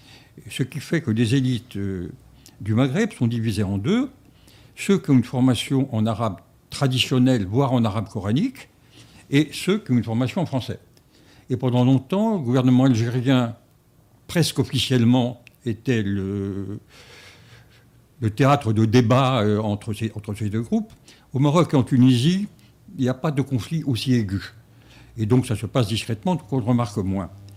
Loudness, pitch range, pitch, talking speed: -22 LUFS, 110-135 Hz, 125 Hz, 160 wpm